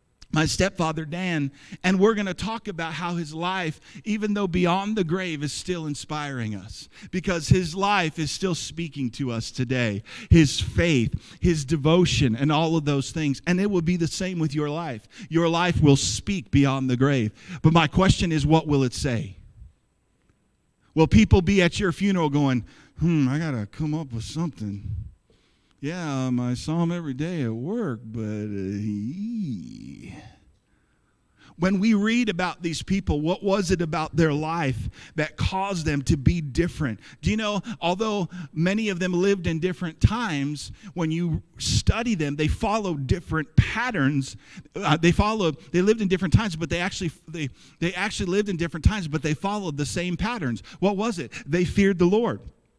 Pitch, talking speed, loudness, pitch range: 160 Hz, 175 wpm, -24 LUFS, 140-185 Hz